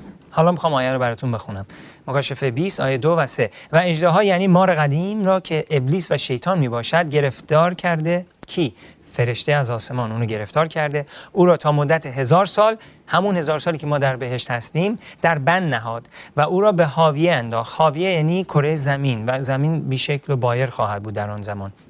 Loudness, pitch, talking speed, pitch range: -20 LUFS, 150 Hz, 190 wpm, 130-170 Hz